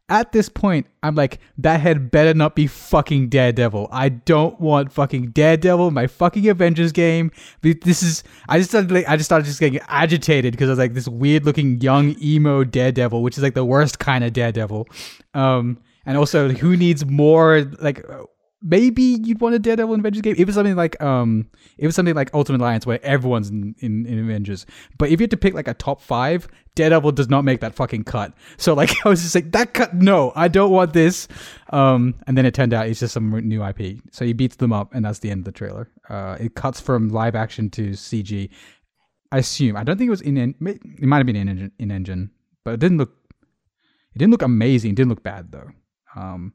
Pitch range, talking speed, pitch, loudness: 115-165 Hz, 225 wpm, 140 Hz, -18 LUFS